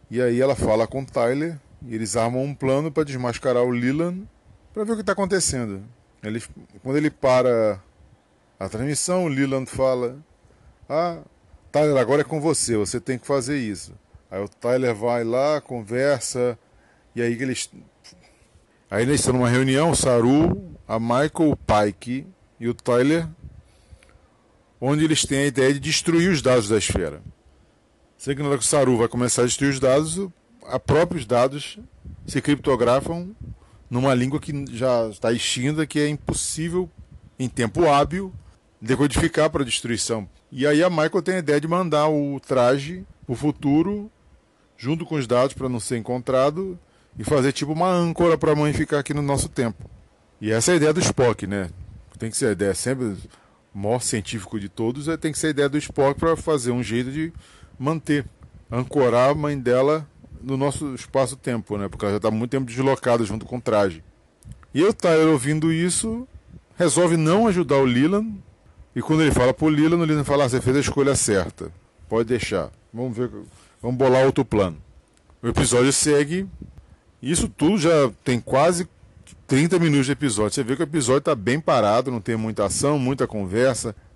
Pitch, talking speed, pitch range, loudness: 130 Hz, 175 wpm, 115-150 Hz, -22 LUFS